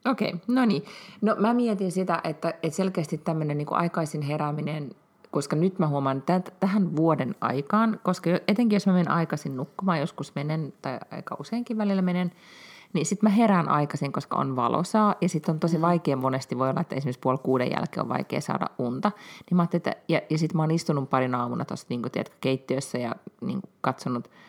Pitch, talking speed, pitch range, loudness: 165 Hz, 200 wpm, 145-195 Hz, -26 LUFS